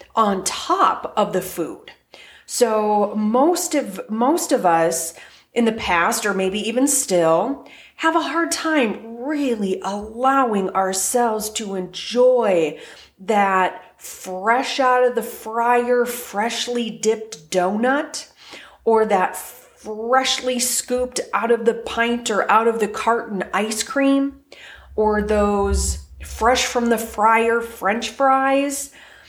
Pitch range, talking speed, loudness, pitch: 200-250 Hz, 120 wpm, -20 LUFS, 230 Hz